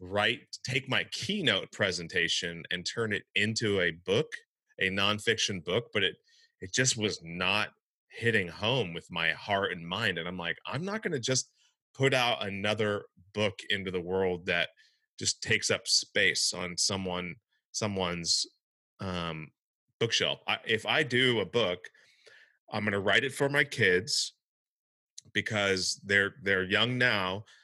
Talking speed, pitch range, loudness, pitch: 150 wpm, 95-130 Hz, -29 LUFS, 105 Hz